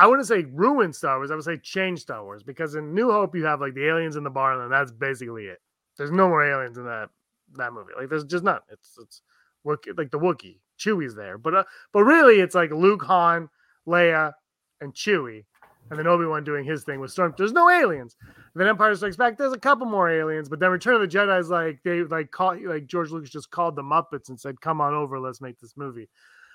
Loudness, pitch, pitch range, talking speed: -22 LUFS, 160 Hz, 140-180 Hz, 240 wpm